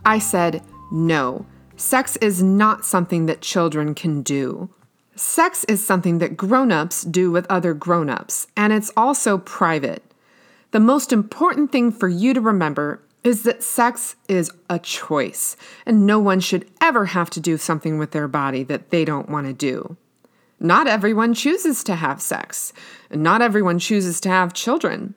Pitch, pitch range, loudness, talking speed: 190 Hz, 165-235 Hz, -19 LUFS, 165 wpm